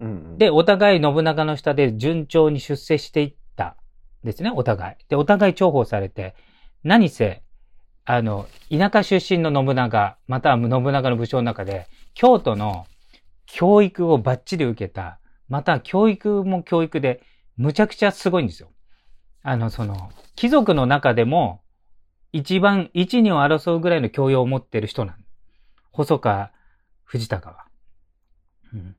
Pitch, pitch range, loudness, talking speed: 130 Hz, 95-165 Hz, -20 LUFS, 265 characters per minute